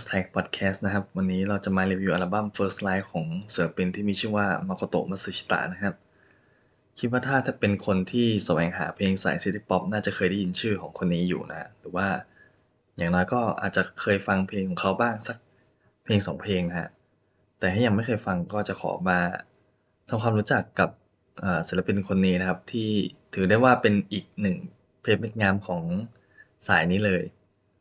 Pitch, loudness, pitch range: 100 Hz, -26 LUFS, 95-105 Hz